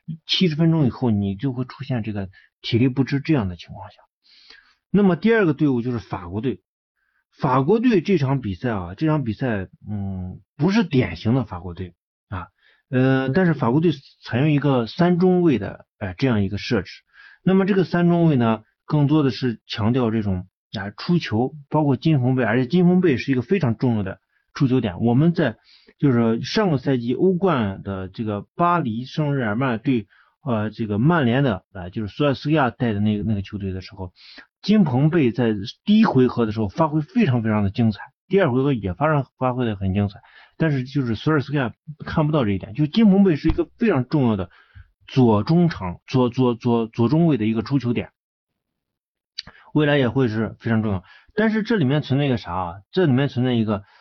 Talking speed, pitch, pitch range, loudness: 300 characters per minute, 125 Hz, 110-155 Hz, -21 LUFS